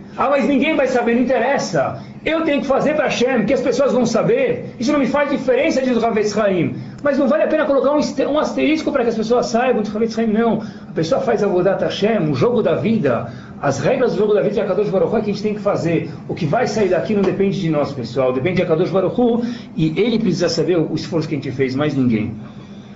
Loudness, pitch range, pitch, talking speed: -18 LUFS, 180-260 Hz, 220 Hz, 240 wpm